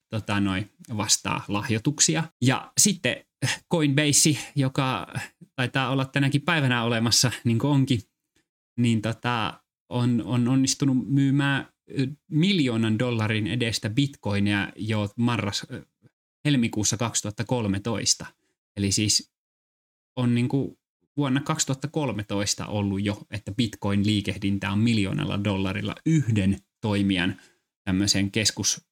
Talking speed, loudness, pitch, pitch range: 100 wpm, -24 LUFS, 120 Hz, 105-135 Hz